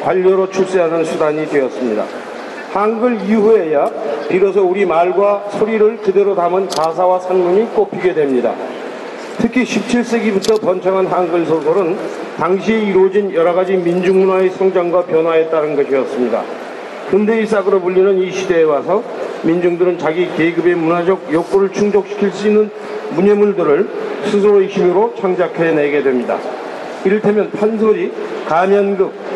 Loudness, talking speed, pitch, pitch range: -14 LUFS, 325 characters per minute, 195 Hz, 175-215 Hz